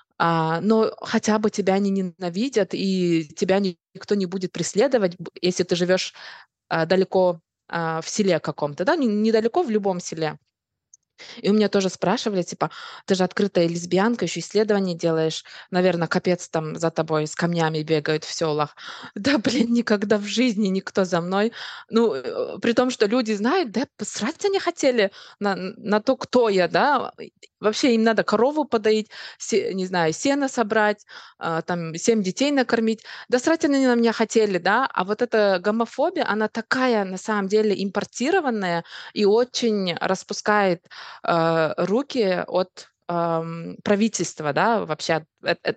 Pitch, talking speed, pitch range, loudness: 200 Hz, 145 wpm, 175-230 Hz, -22 LUFS